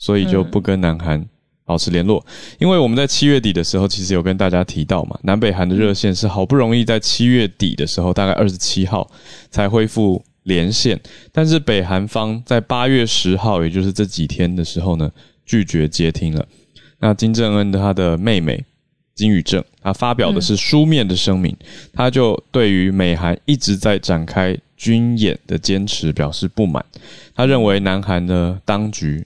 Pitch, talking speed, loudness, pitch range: 100 Hz, 275 characters per minute, -17 LUFS, 90-115 Hz